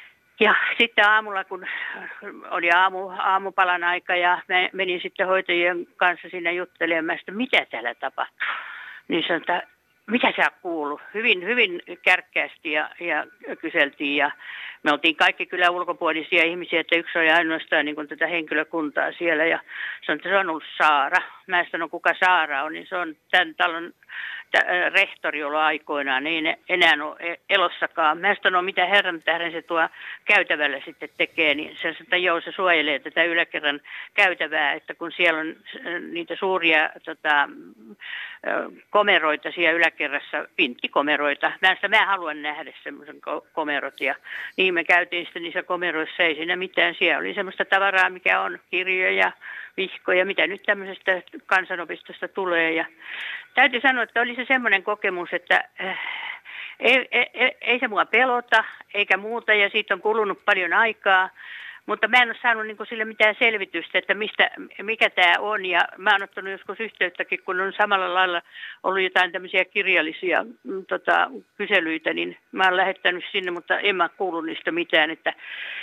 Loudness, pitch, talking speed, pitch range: -22 LUFS, 180 Hz, 150 wpm, 165-200 Hz